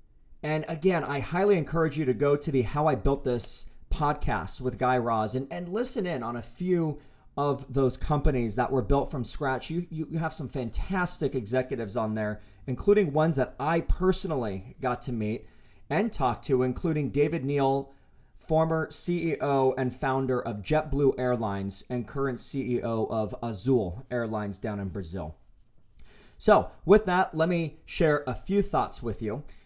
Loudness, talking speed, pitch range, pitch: -28 LUFS, 165 wpm, 120-160 Hz, 135 Hz